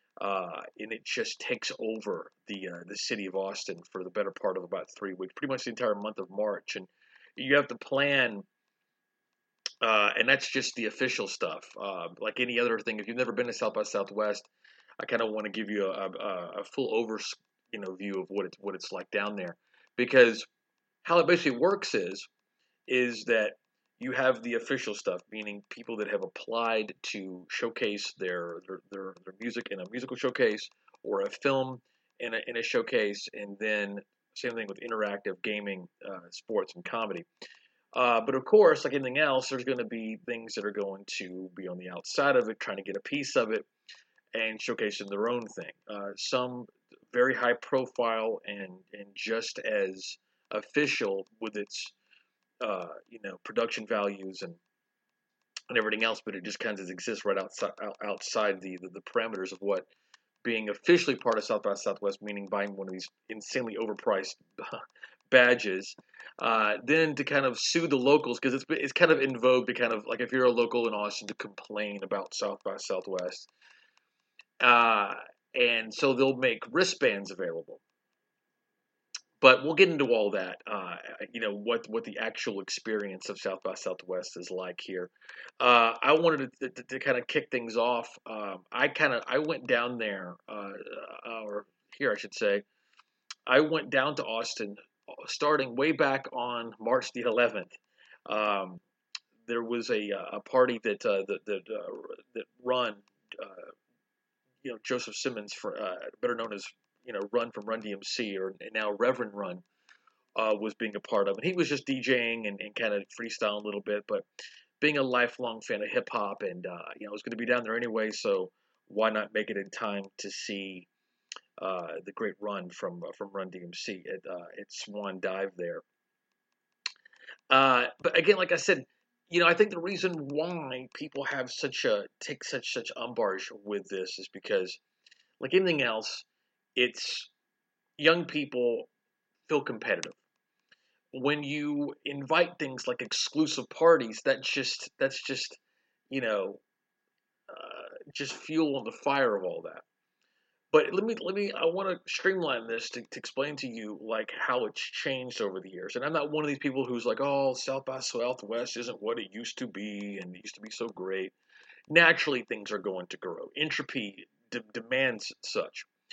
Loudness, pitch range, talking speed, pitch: -30 LUFS, 105-155 Hz, 185 wpm, 120 Hz